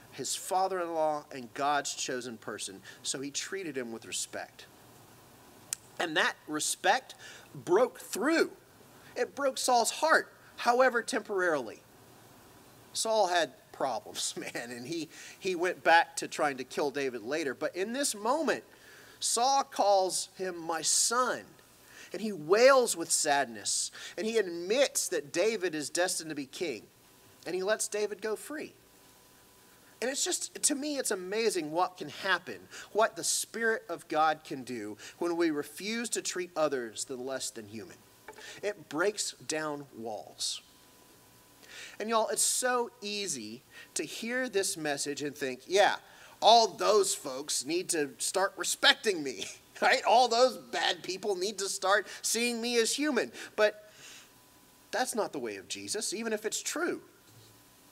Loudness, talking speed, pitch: -30 LUFS, 150 wpm, 200 Hz